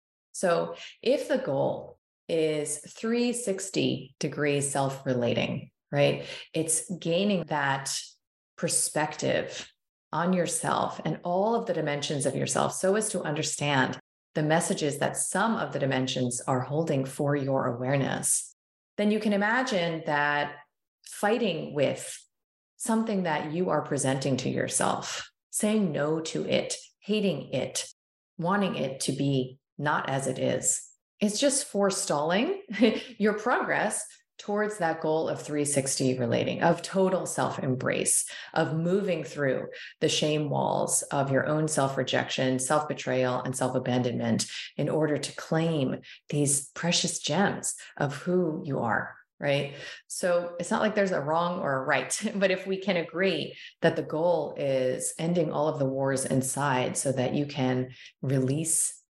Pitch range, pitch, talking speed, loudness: 140-185 Hz, 155 Hz, 140 wpm, -28 LUFS